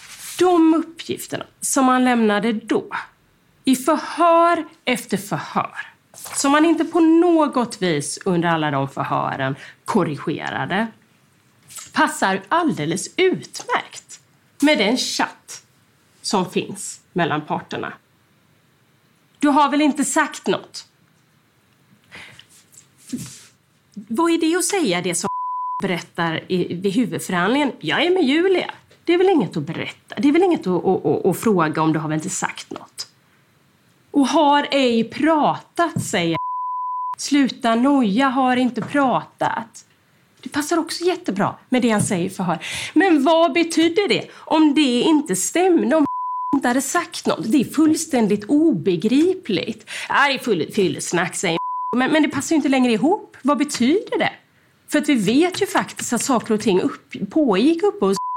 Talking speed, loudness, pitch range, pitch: 140 wpm, -19 LUFS, 200-325 Hz, 275 Hz